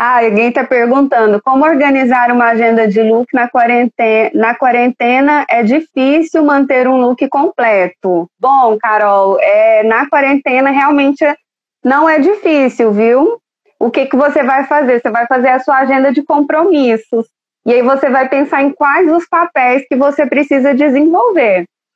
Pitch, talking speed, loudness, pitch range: 270 Hz, 155 wpm, -10 LUFS, 240-290 Hz